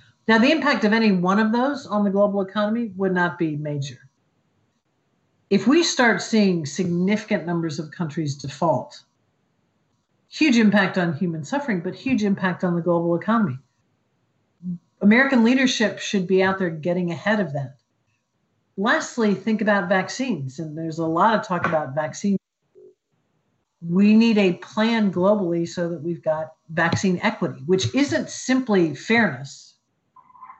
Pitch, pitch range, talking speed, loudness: 190 Hz, 170-220 Hz, 145 wpm, -21 LUFS